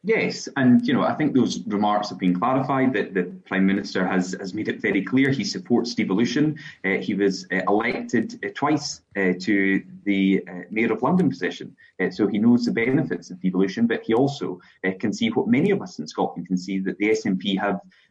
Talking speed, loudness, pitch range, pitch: 215 wpm, -23 LUFS, 95-130 Hz, 100 Hz